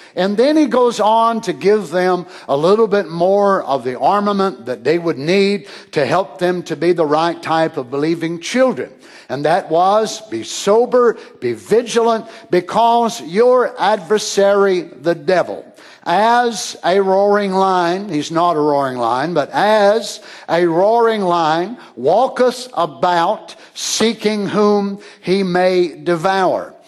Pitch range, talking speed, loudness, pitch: 170-220 Hz, 140 wpm, -15 LUFS, 195 Hz